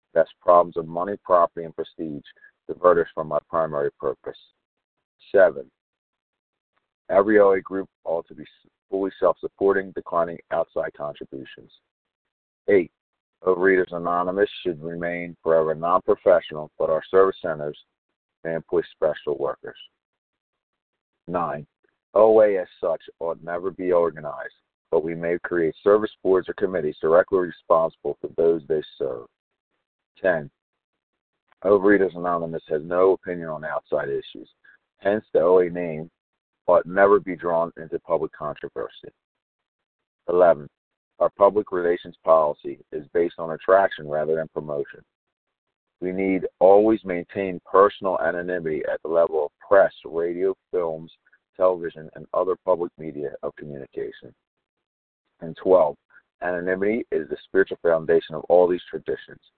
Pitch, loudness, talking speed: 95 Hz, -22 LUFS, 125 wpm